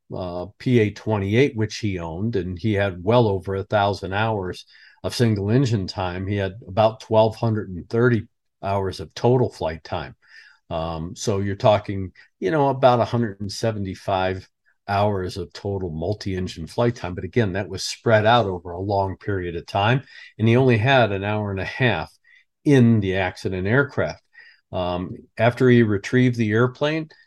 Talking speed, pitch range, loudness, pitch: 160 wpm, 95-120 Hz, -22 LUFS, 105 Hz